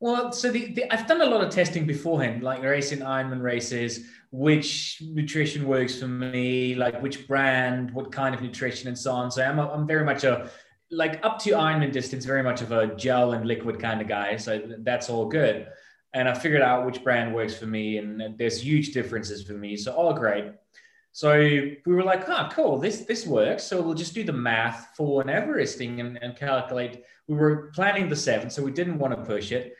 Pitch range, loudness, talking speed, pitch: 120-150 Hz, -25 LUFS, 220 wpm, 130 Hz